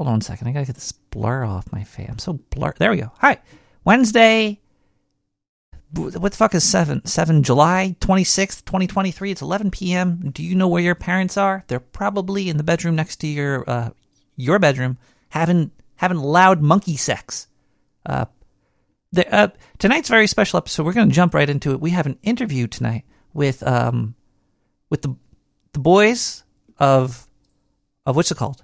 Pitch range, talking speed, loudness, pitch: 130-190 Hz, 185 wpm, -19 LUFS, 160 Hz